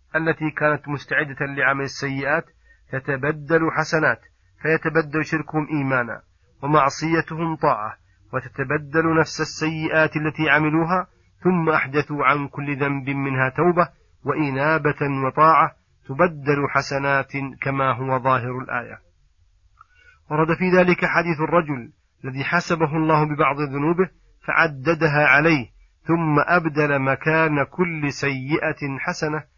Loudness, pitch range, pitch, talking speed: -21 LUFS, 140-160 Hz, 150 Hz, 100 wpm